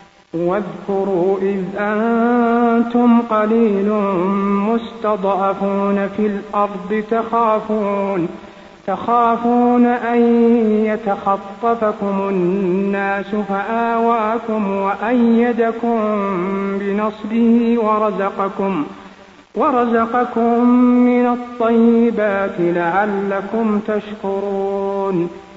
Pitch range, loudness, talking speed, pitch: 195-230 Hz, -17 LUFS, 50 wpm, 210 Hz